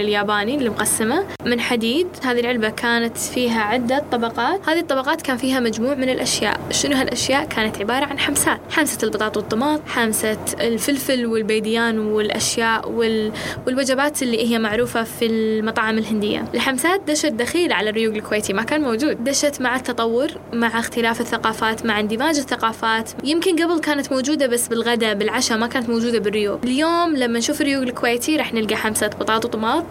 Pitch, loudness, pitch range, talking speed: 235 Hz, -20 LUFS, 225-275 Hz, 155 wpm